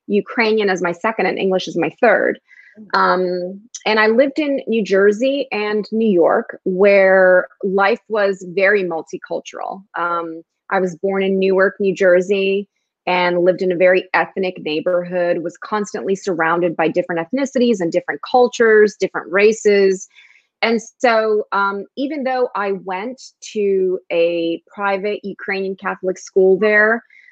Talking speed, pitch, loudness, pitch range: 140 wpm, 195 Hz, -17 LUFS, 185-215 Hz